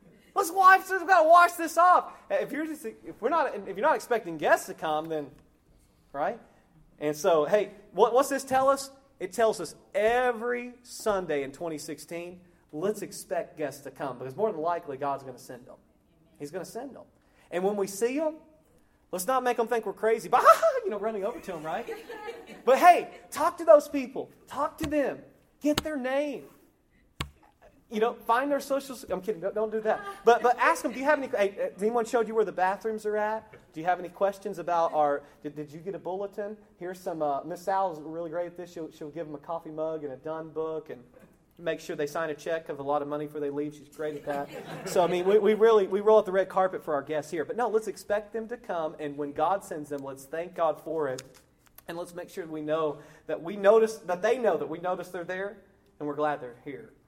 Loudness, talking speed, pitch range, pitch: -28 LUFS, 240 wpm, 155-235 Hz, 190 Hz